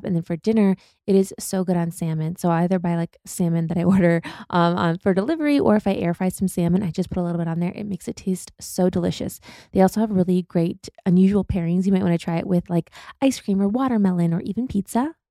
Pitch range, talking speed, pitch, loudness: 170-195 Hz, 260 wpm, 185 Hz, -22 LUFS